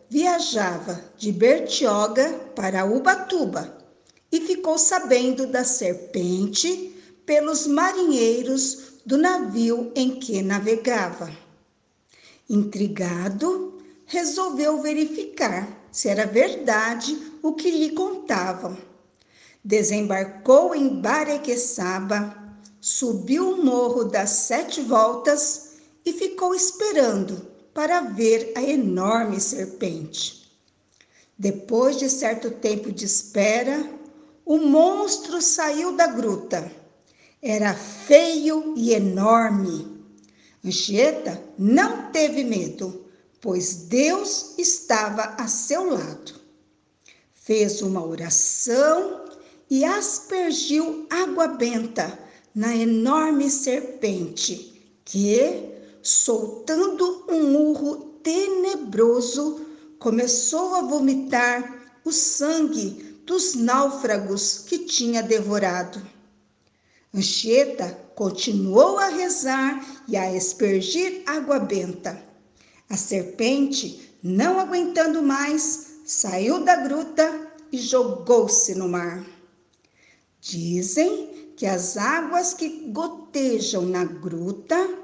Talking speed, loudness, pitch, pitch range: 85 wpm, -22 LUFS, 255 Hz, 205-315 Hz